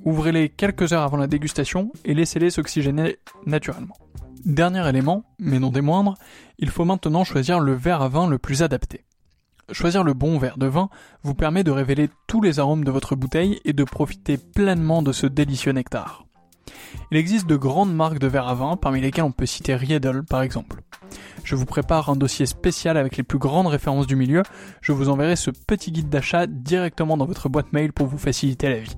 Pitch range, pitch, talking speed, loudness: 135-170 Hz, 150 Hz, 205 wpm, -22 LUFS